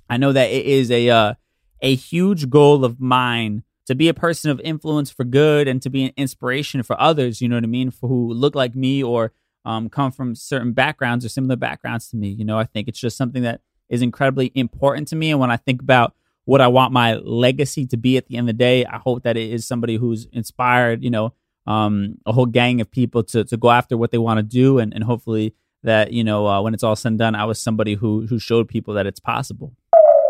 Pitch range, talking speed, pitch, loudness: 115-130 Hz, 250 wpm, 125 Hz, -18 LUFS